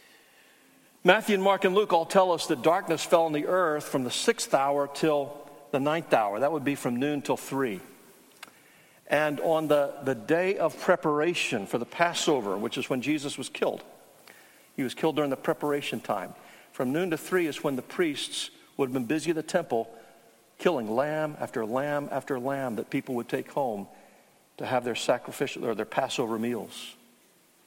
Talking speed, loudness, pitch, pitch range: 185 wpm, -28 LUFS, 150 Hz, 135-170 Hz